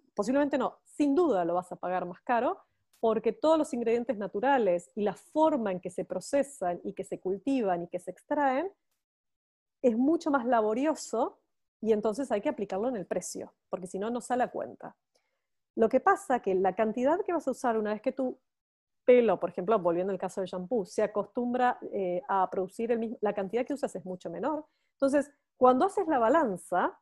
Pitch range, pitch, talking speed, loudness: 190-275 Hz, 230 Hz, 200 wpm, -30 LUFS